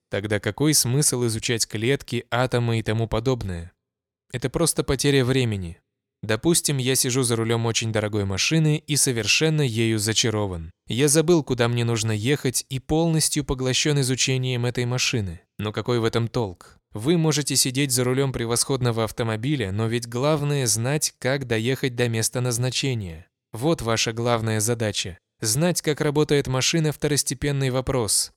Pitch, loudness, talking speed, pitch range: 125 Hz, -22 LUFS, 145 wpm, 115-140 Hz